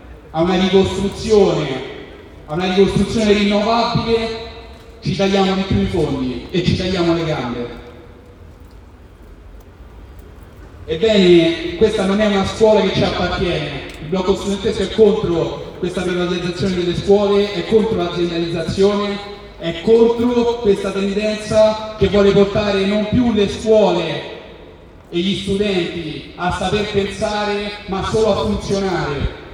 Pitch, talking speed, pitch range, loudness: 195 Hz, 120 wpm, 165-205 Hz, -17 LUFS